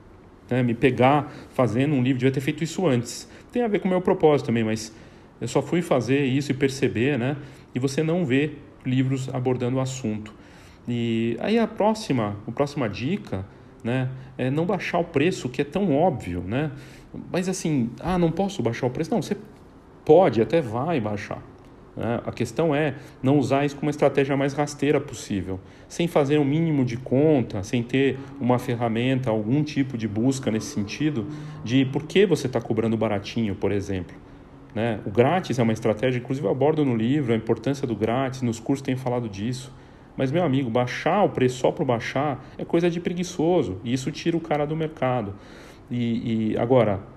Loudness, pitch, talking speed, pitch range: -24 LUFS, 130 Hz, 185 wpm, 115-150 Hz